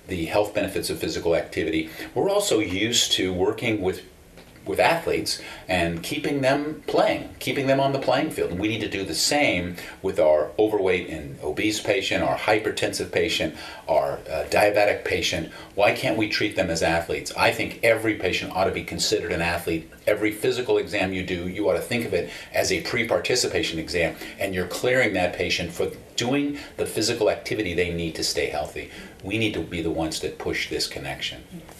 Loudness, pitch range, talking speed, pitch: -24 LUFS, 85-140 Hz, 190 wpm, 105 Hz